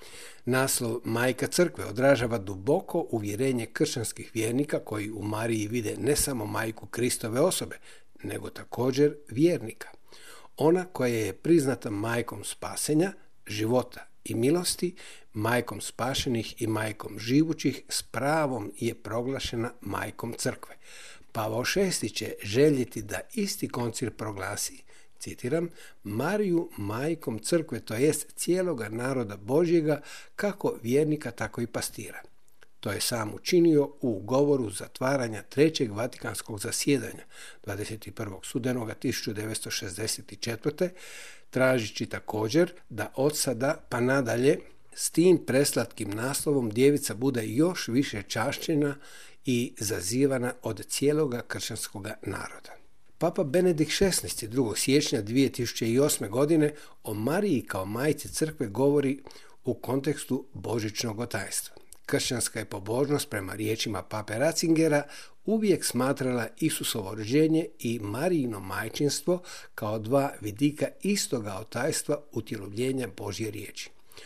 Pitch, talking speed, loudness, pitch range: 125 Hz, 110 wpm, -28 LUFS, 110-150 Hz